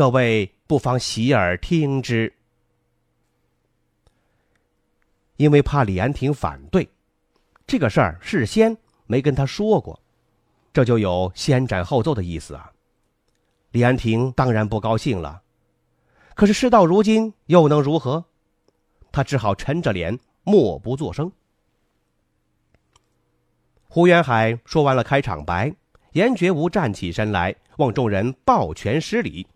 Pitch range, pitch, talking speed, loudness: 95-150 Hz, 125 Hz, 185 characters per minute, -20 LUFS